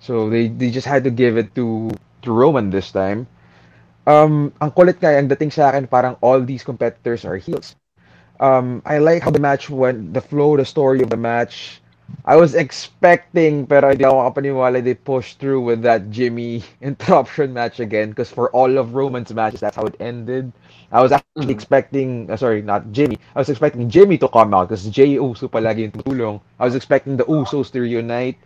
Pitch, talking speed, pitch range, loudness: 125 Hz, 190 wpm, 115-140 Hz, -17 LUFS